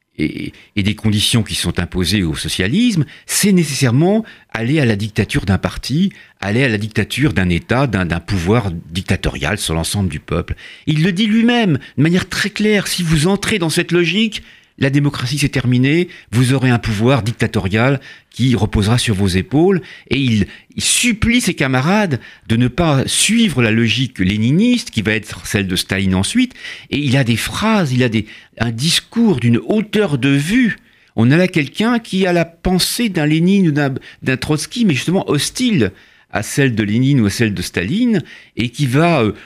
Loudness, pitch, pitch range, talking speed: -16 LUFS, 135 Hz, 110-180 Hz, 185 wpm